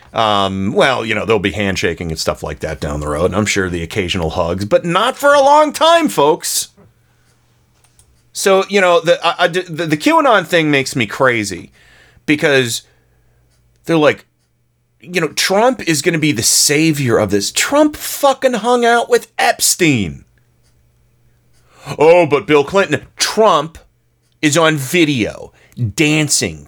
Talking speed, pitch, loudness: 155 wpm, 145 Hz, -14 LUFS